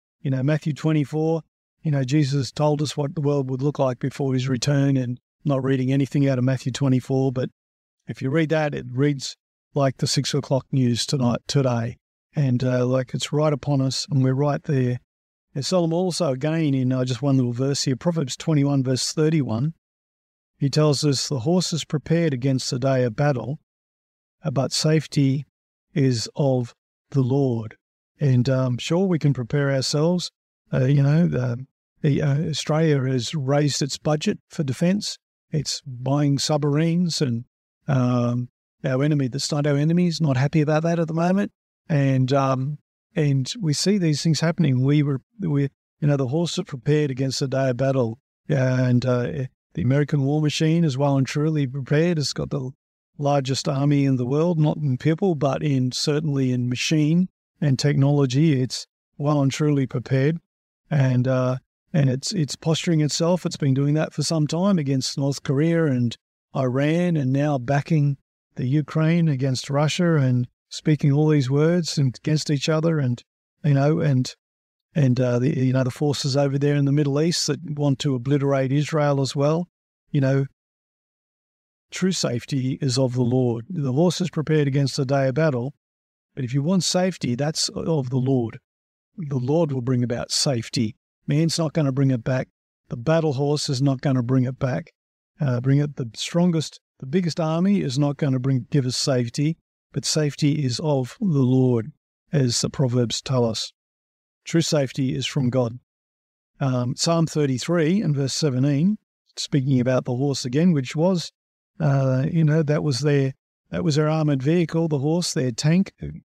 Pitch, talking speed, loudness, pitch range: 140 Hz, 180 wpm, -22 LUFS, 130-155 Hz